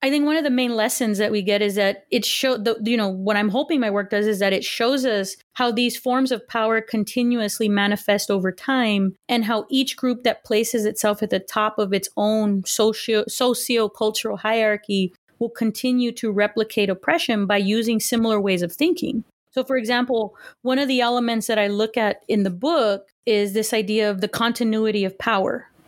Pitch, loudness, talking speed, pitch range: 220 Hz, -21 LUFS, 200 wpm, 210-240 Hz